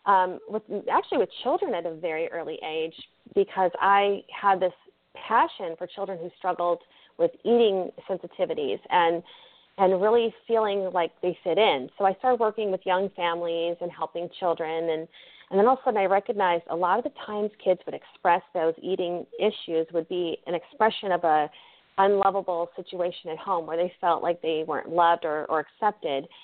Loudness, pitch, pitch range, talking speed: -26 LUFS, 180 Hz, 170-200 Hz, 180 wpm